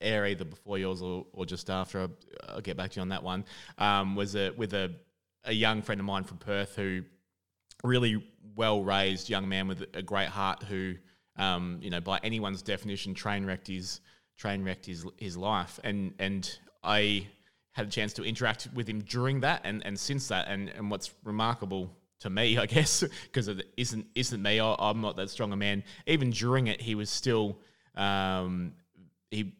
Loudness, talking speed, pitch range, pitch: -32 LUFS, 195 wpm, 95-110 Hz, 100 Hz